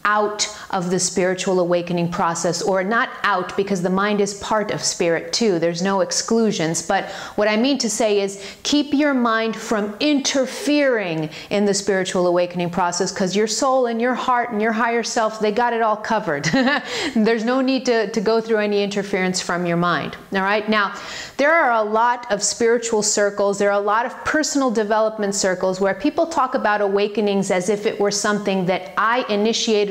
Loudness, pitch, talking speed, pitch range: -19 LUFS, 210 Hz, 190 wpm, 195-230 Hz